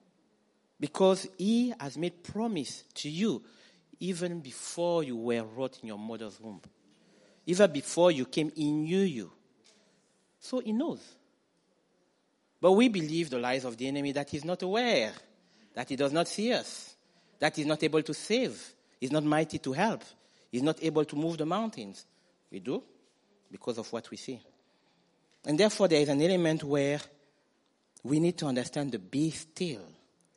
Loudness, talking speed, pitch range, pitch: -30 LUFS, 165 wpm, 145-190 Hz, 160 Hz